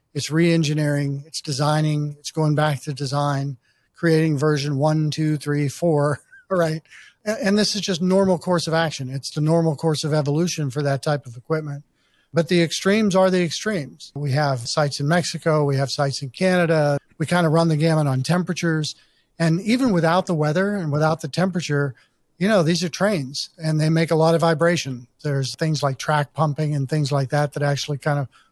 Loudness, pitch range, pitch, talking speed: -21 LUFS, 145-170 Hz, 155 Hz, 195 wpm